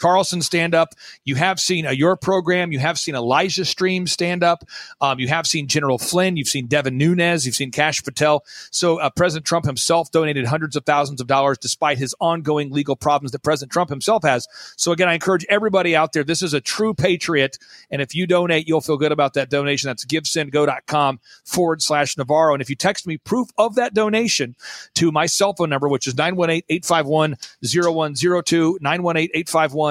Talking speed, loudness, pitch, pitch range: 195 wpm, -19 LUFS, 160 Hz, 145-175 Hz